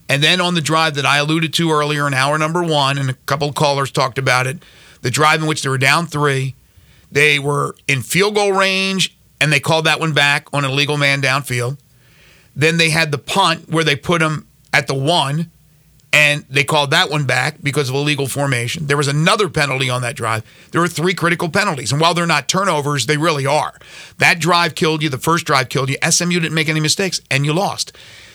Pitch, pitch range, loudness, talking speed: 150 Hz, 140-165 Hz, -15 LUFS, 225 wpm